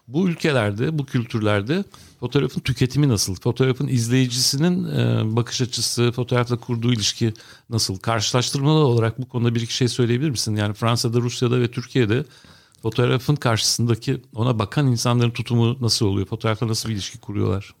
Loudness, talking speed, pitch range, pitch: -21 LUFS, 140 wpm, 115-130 Hz, 120 Hz